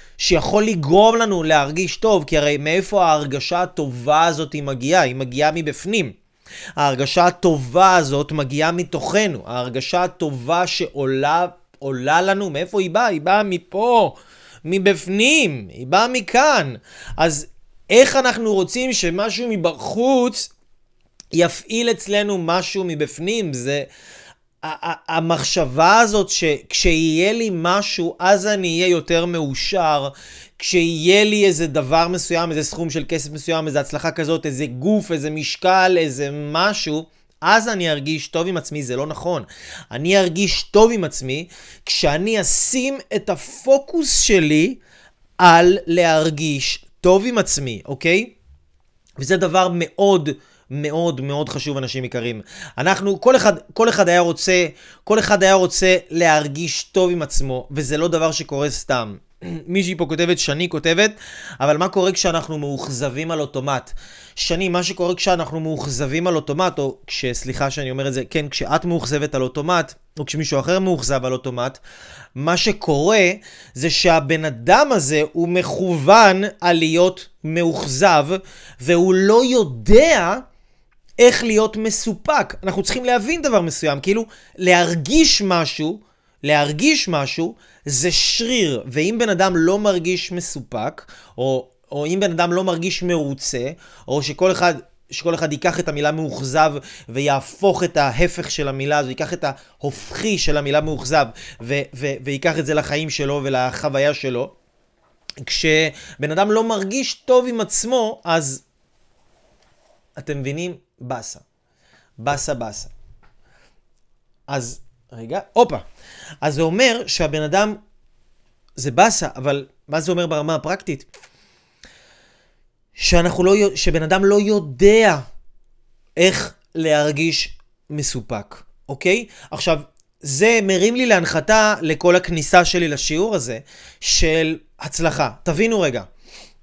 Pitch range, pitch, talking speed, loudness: 145-190 Hz, 165 Hz, 125 wpm, -18 LUFS